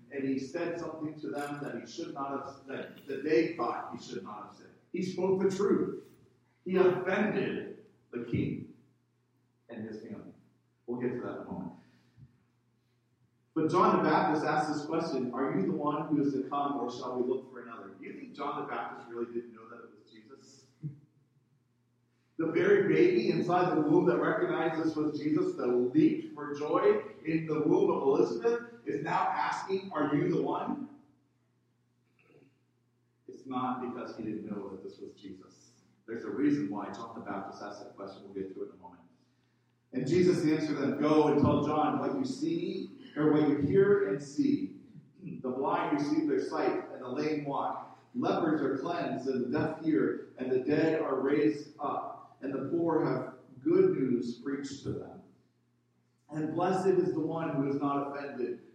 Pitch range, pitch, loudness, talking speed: 125-180 Hz, 145 Hz, -31 LUFS, 185 wpm